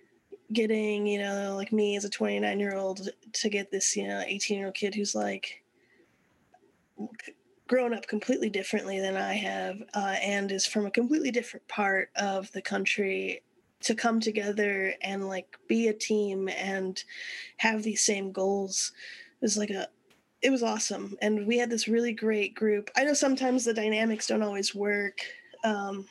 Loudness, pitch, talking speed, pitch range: -29 LUFS, 210 Hz, 170 wpm, 195-230 Hz